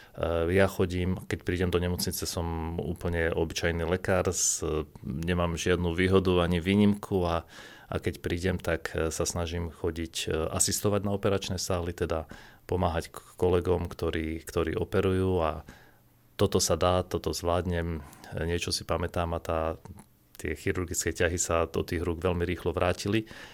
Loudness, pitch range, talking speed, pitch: -29 LUFS, 85-95 Hz, 140 wpm, 90 Hz